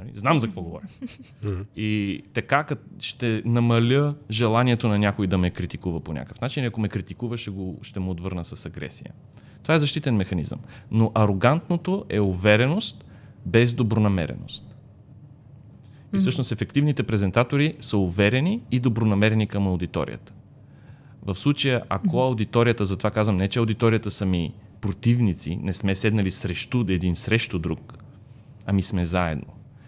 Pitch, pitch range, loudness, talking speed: 110 Hz, 100-125 Hz, -24 LUFS, 140 wpm